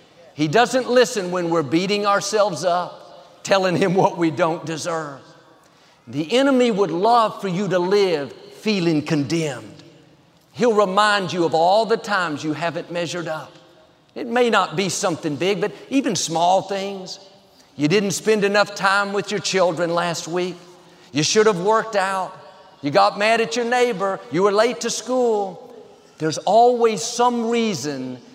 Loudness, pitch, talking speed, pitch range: -20 LUFS, 190 Hz, 160 wpm, 165-215 Hz